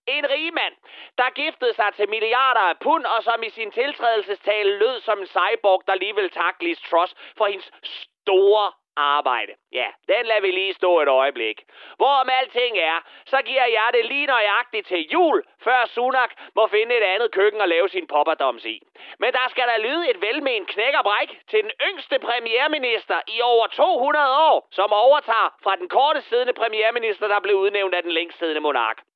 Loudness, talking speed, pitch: -20 LUFS, 180 wpm, 245 Hz